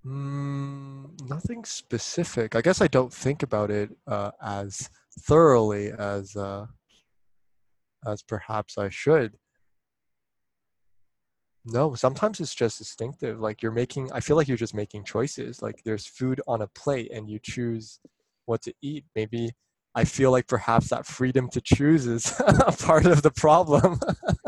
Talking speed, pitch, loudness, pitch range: 150 wpm, 115 Hz, -25 LUFS, 105-140 Hz